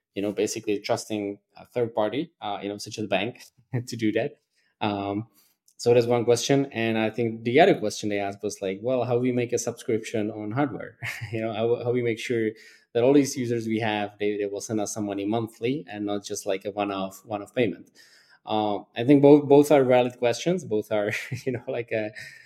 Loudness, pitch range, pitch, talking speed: -25 LUFS, 105-120 Hz, 110 Hz, 225 wpm